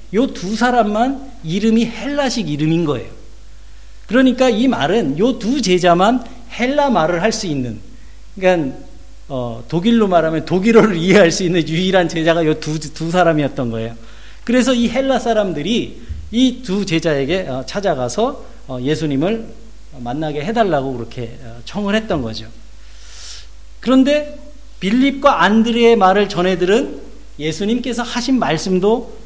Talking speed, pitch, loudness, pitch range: 290 characters per minute, 190 Hz, -16 LUFS, 150-235 Hz